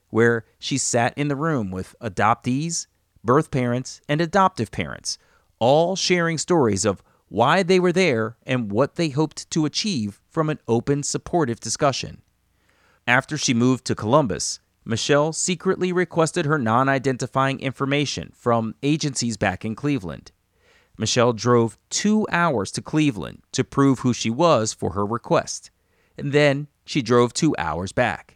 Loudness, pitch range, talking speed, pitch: -22 LUFS, 115-155 Hz, 150 wpm, 135 Hz